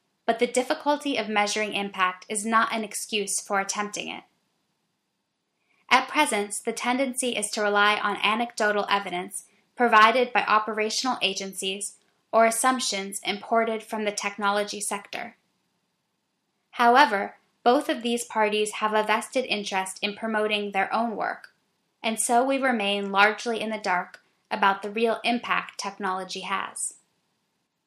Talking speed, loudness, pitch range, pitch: 135 wpm, -25 LUFS, 200-230 Hz, 215 Hz